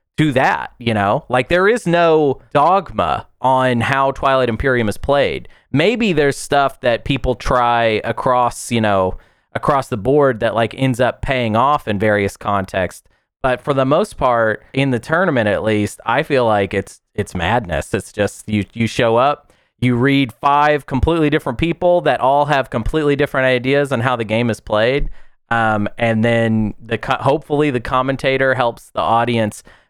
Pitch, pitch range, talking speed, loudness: 125 Hz, 115-140 Hz, 175 wpm, -16 LUFS